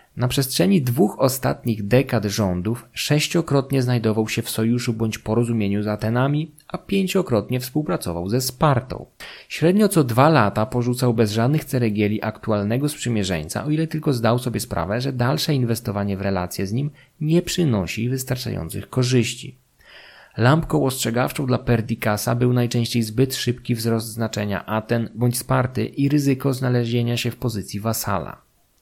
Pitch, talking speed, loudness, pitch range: 120 Hz, 140 wpm, -21 LUFS, 110-135 Hz